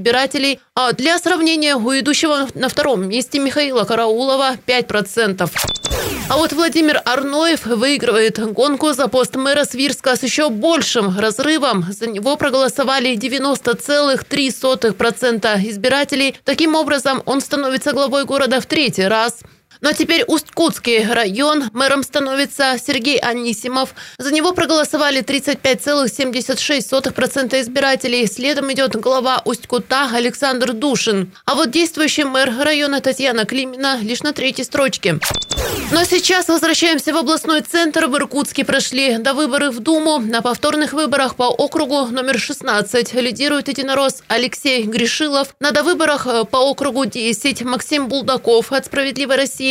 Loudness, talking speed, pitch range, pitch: -16 LUFS, 130 wpm, 245-290 Hz, 270 Hz